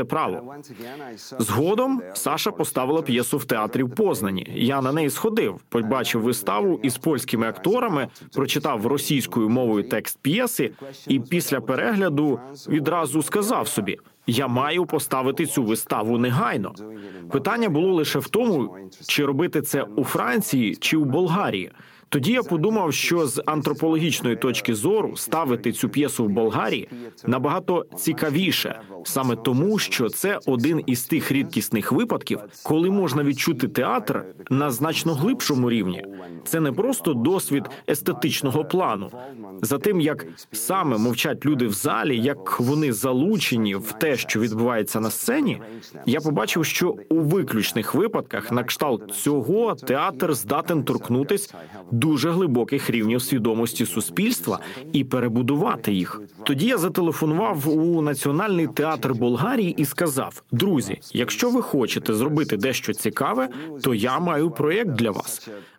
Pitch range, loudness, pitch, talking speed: 120-160 Hz, -23 LUFS, 140 Hz, 130 wpm